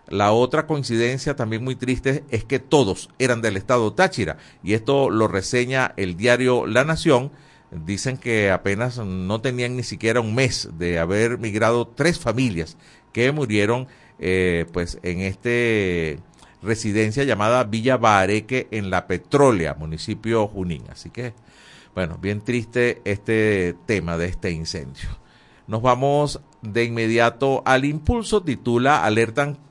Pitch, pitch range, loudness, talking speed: 115 Hz, 100-130 Hz, -21 LUFS, 135 wpm